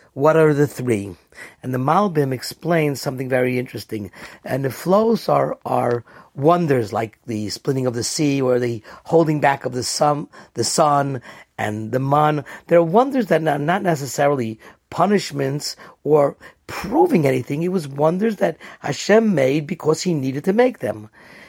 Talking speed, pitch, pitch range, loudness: 160 wpm, 140 Hz, 125-165 Hz, -19 LUFS